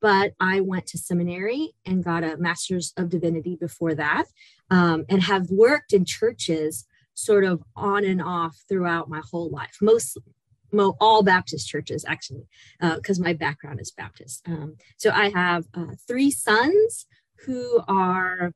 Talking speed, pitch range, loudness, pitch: 160 wpm, 165-200 Hz, -23 LUFS, 180 Hz